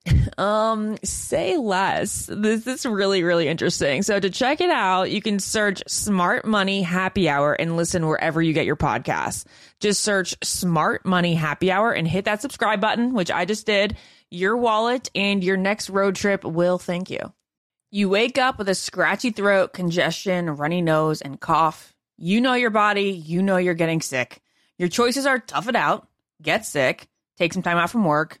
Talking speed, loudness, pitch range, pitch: 185 wpm, -21 LUFS, 175-215 Hz, 190 Hz